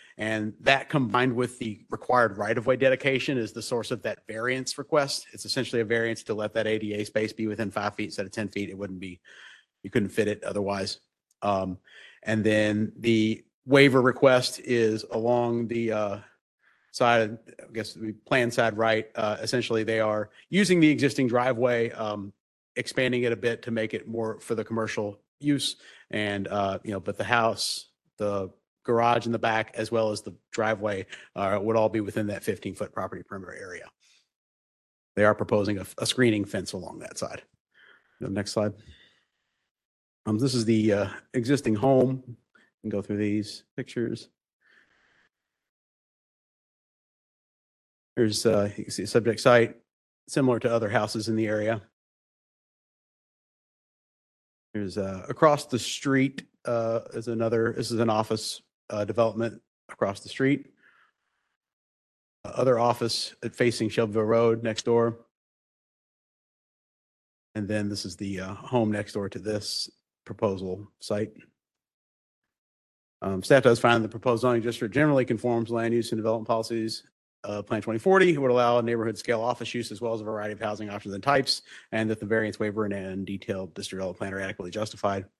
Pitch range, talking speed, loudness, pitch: 105-120 Hz, 165 wpm, -27 LUFS, 110 Hz